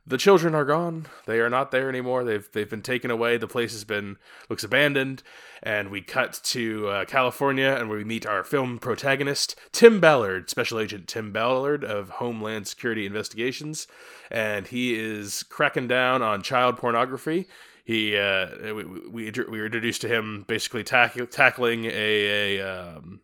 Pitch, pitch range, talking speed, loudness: 115 Hz, 105-130 Hz, 170 wpm, -24 LUFS